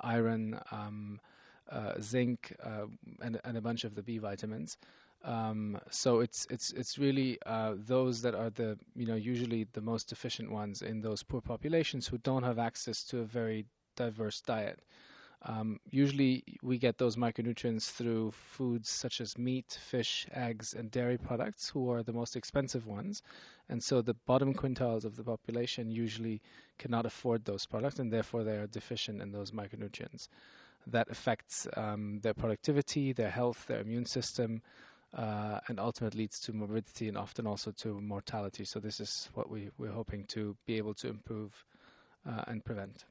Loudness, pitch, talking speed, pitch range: -37 LUFS, 115 Hz, 170 wpm, 110-125 Hz